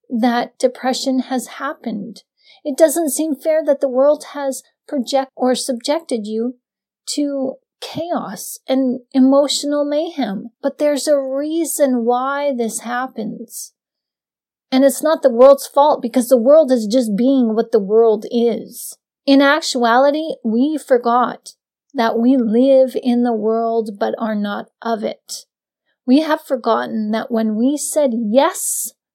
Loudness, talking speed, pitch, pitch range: -17 LUFS, 140 wpm, 260 Hz, 235-285 Hz